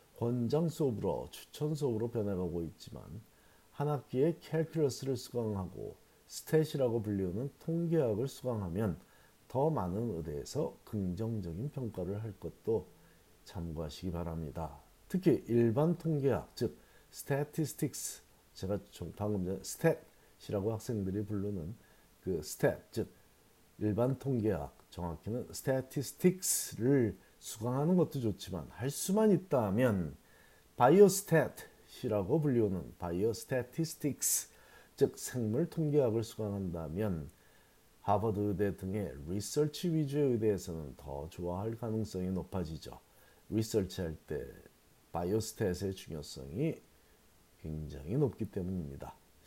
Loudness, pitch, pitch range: -35 LUFS, 110 Hz, 90-140 Hz